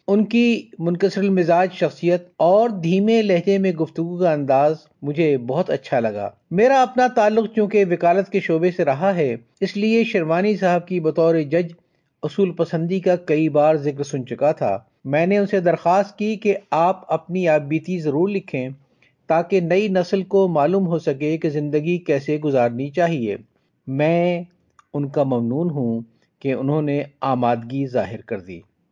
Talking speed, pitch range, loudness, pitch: 160 wpm, 150-195 Hz, -20 LUFS, 170 Hz